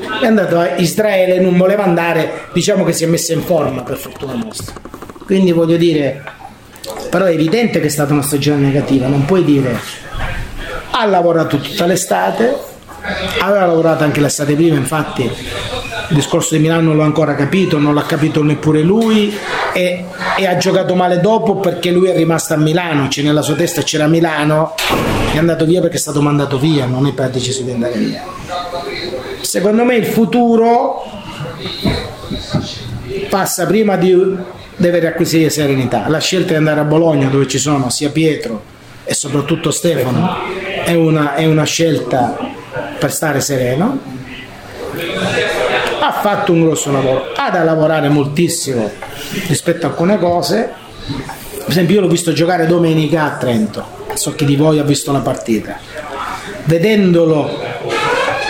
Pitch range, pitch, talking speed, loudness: 145-180 Hz, 160 Hz, 155 wpm, -14 LUFS